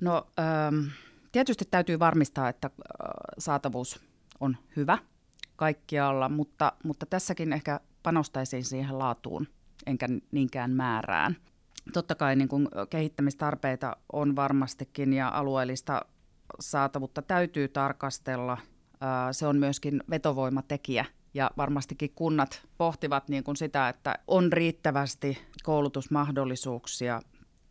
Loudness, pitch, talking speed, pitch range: -30 LUFS, 140 Hz, 95 wpm, 135-155 Hz